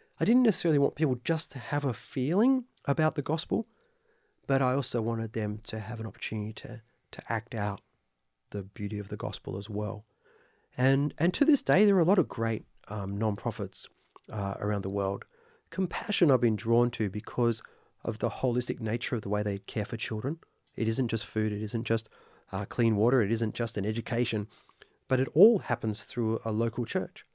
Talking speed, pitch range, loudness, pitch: 195 wpm, 105-140 Hz, -30 LUFS, 115 Hz